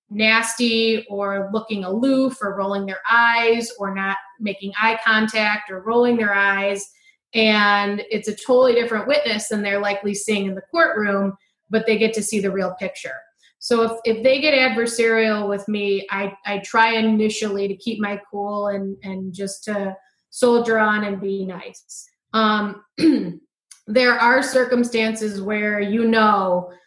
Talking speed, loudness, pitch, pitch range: 155 wpm, -19 LUFS, 215 Hz, 200-230 Hz